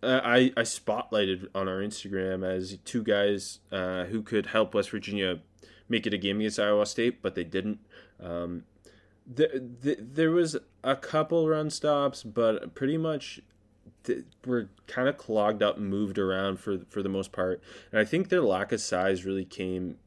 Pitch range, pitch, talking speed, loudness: 95-120 Hz, 105 Hz, 180 wpm, -29 LUFS